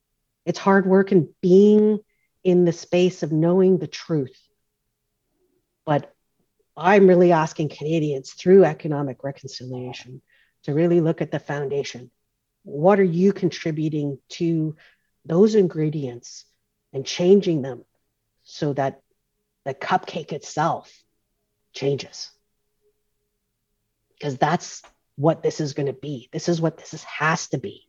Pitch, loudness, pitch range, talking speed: 155 Hz, -21 LUFS, 135-180 Hz, 125 wpm